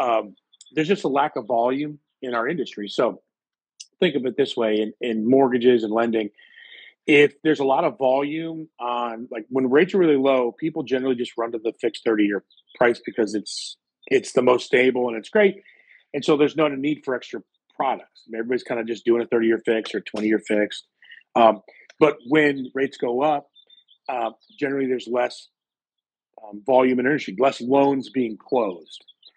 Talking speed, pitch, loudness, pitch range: 190 wpm, 130 Hz, -22 LUFS, 115-145 Hz